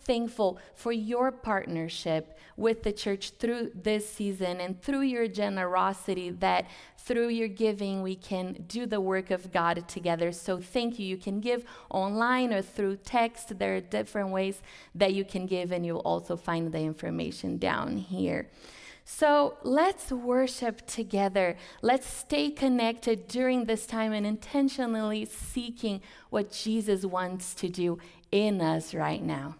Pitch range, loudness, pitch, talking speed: 185-235 Hz, -30 LUFS, 205 Hz, 150 wpm